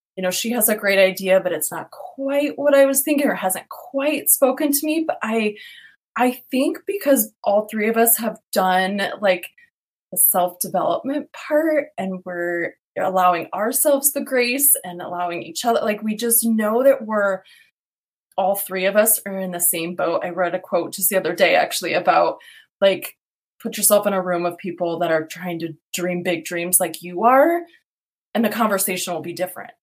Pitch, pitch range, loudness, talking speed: 205 Hz, 180-270 Hz, -19 LUFS, 190 wpm